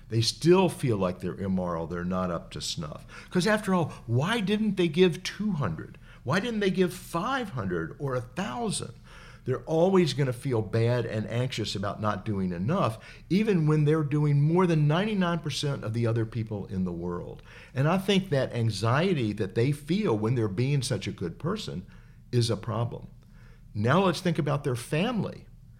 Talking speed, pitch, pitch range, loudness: 175 wpm, 130 Hz, 110-170 Hz, -28 LUFS